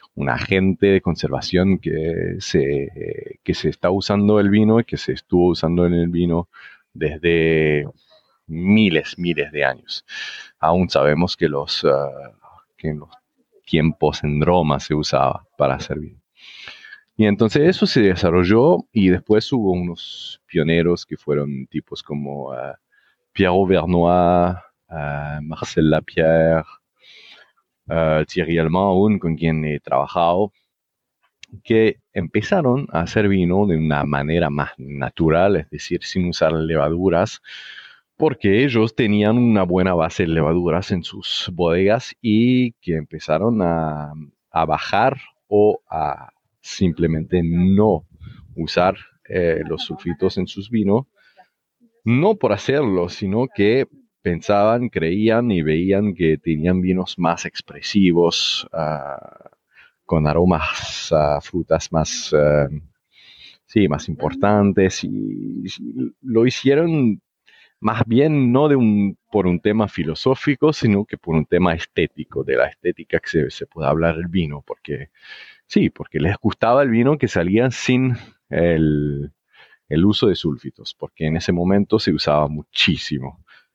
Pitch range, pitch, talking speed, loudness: 80-105 Hz, 90 Hz, 130 wpm, -19 LUFS